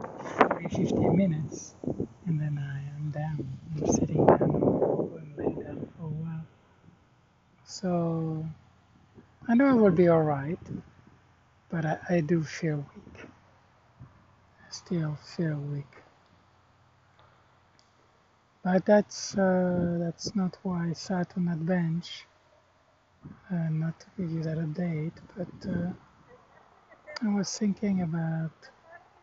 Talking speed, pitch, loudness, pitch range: 115 wpm, 160 Hz, -29 LUFS, 125-180 Hz